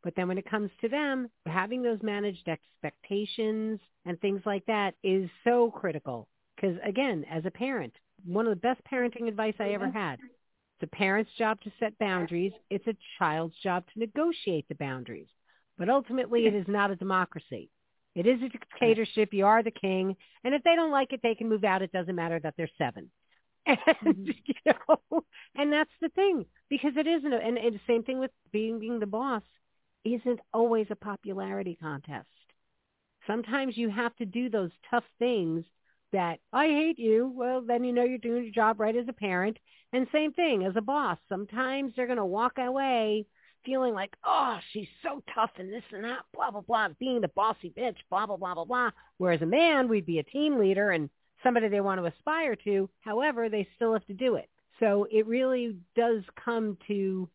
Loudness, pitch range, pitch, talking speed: -29 LUFS, 195-250 Hz, 220 Hz, 195 wpm